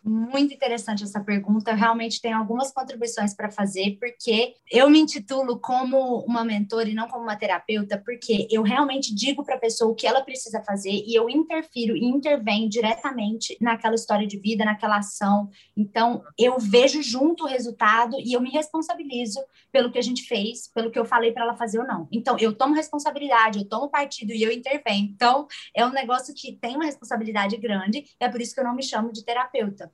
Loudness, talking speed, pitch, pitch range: -23 LUFS, 200 wpm, 235 Hz, 220-260 Hz